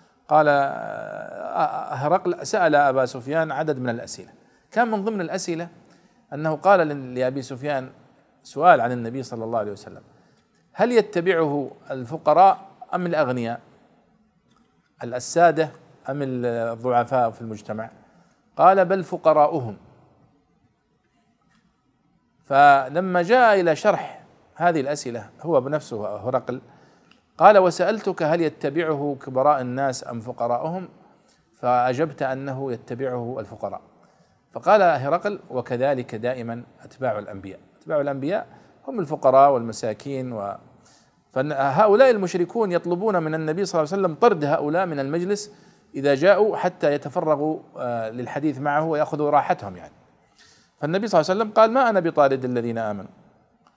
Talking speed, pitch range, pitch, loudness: 115 wpm, 125-175 Hz, 145 Hz, -22 LUFS